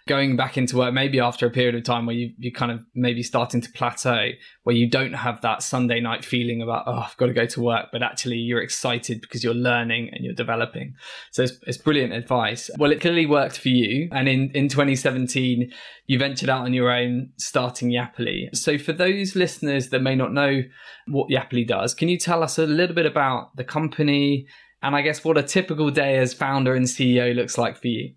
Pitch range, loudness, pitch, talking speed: 120-140 Hz, -22 LUFS, 125 Hz, 220 wpm